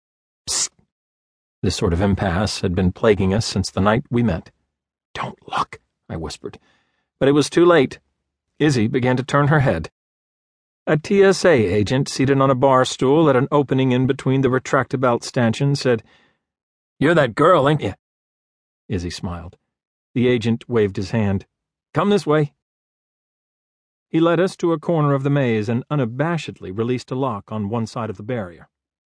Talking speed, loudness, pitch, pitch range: 165 wpm, -19 LUFS, 120 Hz, 95-140 Hz